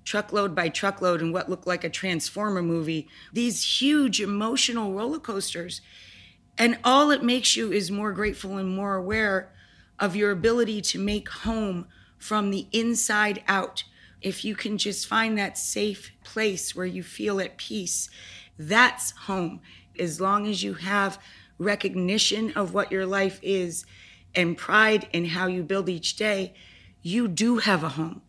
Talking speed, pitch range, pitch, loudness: 160 wpm, 180-215 Hz, 195 Hz, -25 LUFS